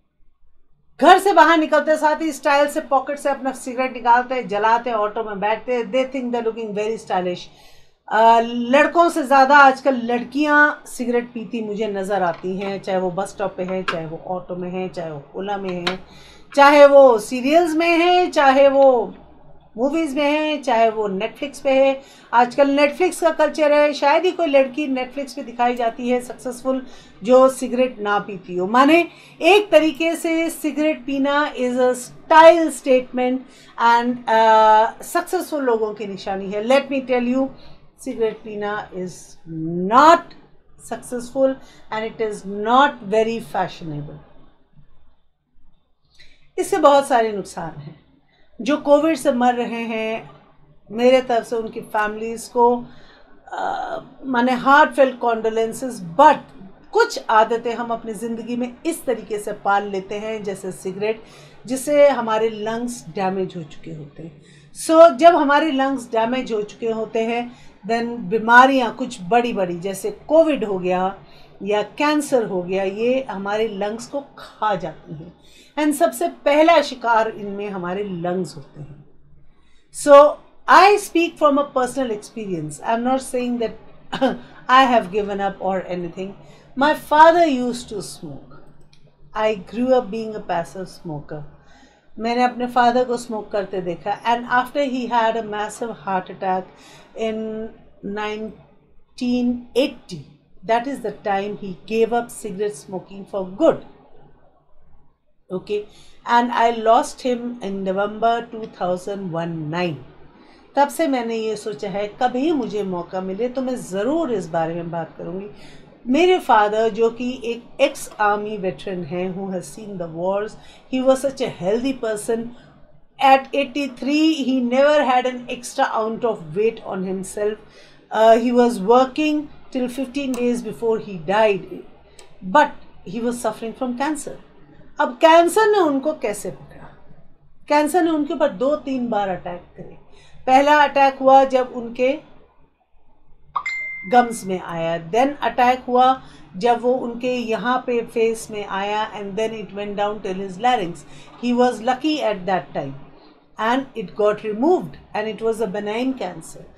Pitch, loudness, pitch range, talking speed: 230 Hz, -19 LUFS, 200-270 Hz, 140 wpm